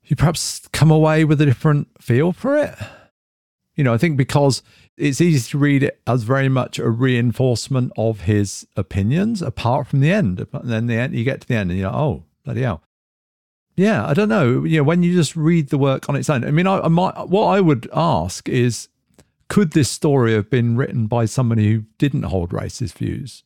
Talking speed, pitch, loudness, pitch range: 215 wpm, 135 Hz, -18 LUFS, 115-155 Hz